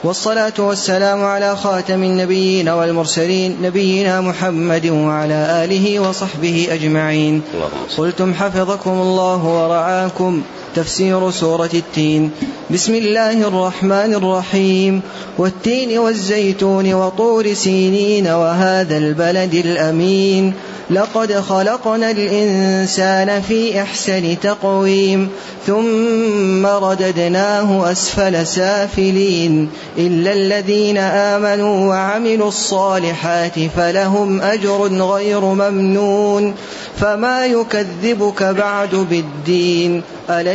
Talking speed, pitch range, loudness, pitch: 80 wpm, 175-200 Hz, -15 LUFS, 190 Hz